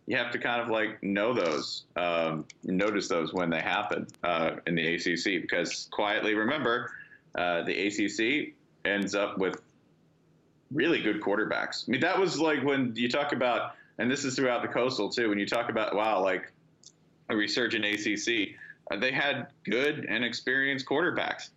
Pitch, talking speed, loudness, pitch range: 120 Hz, 170 wpm, -29 LUFS, 100-155 Hz